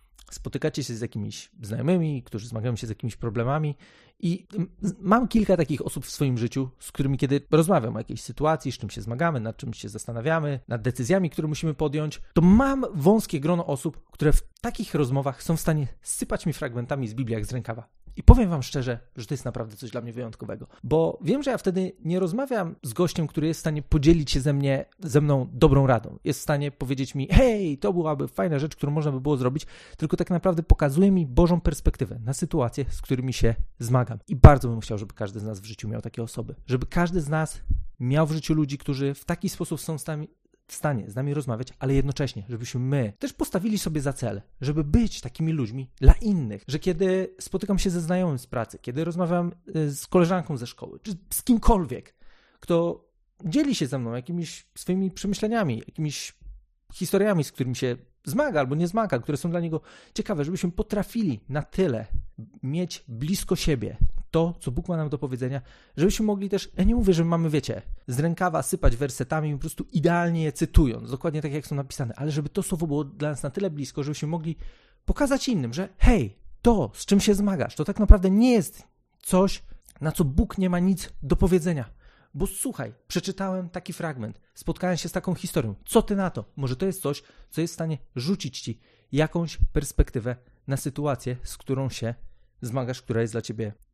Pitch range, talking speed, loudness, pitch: 130-180 Hz, 200 wpm, -26 LUFS, 150 Hz